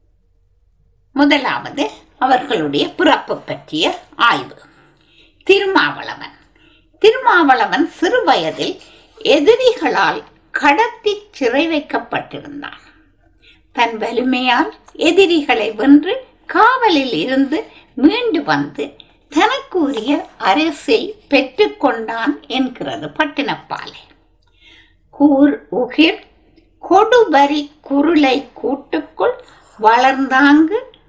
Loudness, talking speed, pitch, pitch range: -15 LUFS, 60 wpm, 295 Hz, 255-395 Hz